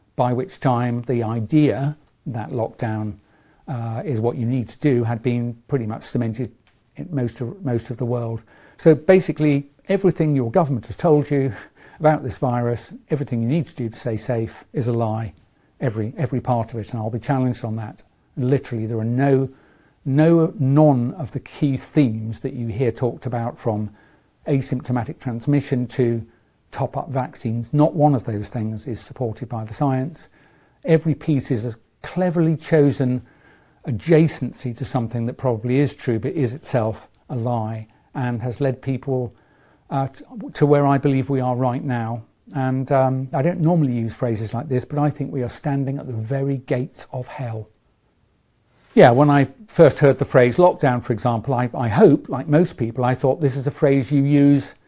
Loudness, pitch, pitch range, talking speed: -21 LUFS, 130 Hz, 120-145 Hz, 185 wpm